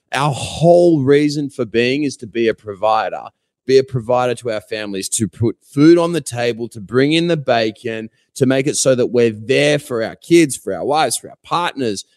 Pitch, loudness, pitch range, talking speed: 125 Hz, -16 LUFS, 115-145 Hz, 210 wpm